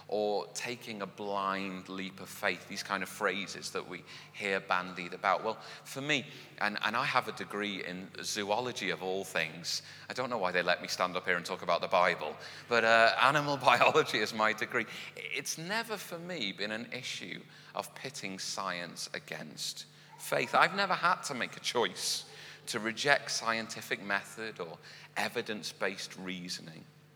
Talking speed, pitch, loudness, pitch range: 175 wpm, 105 Hz, -33 LUFS, 95-125 Hz